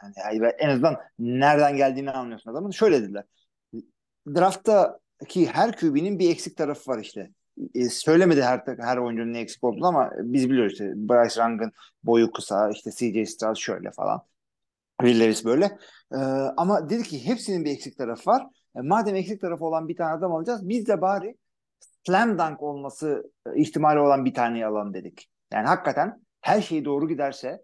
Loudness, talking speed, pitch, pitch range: -24 LUFS, 165 wpm, 140 Hz, 115-170 Hz